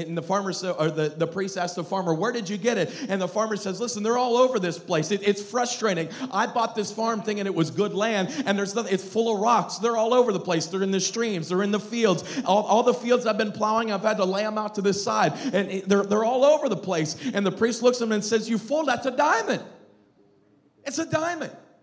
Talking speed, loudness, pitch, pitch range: 265 wpm, -24 LUFS, 210 Hz, 190-235 Hz